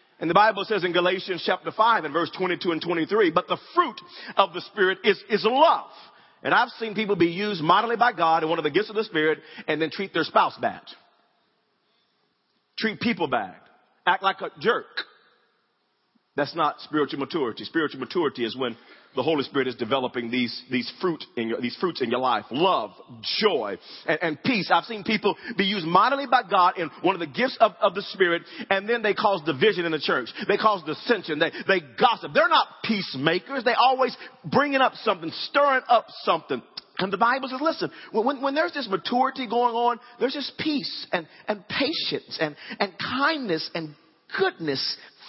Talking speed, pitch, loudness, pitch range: 195 wpm, 200 Hz, -24 LUFS, 165-240 Hz